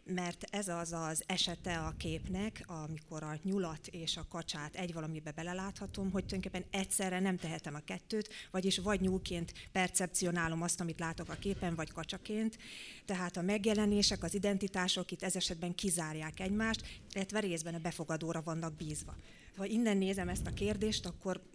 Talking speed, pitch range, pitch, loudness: 160 wpm, 165-195 Hz, 180 Hz, -37 LUFS